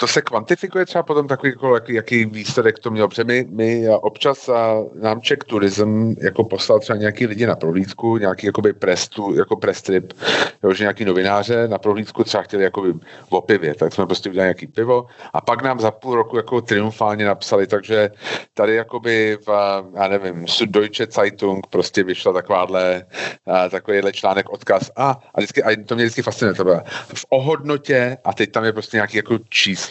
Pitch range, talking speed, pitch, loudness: 100-120 Hz, 180 wpm, 110 Hz, -18 LUFS